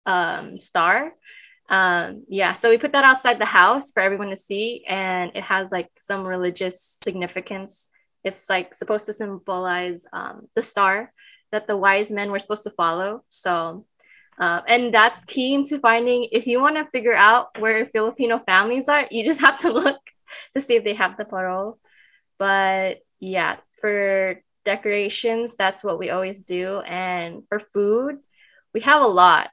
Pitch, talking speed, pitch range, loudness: 205 Hz, 170 wpm, 190-235 Hz, -20 LUFS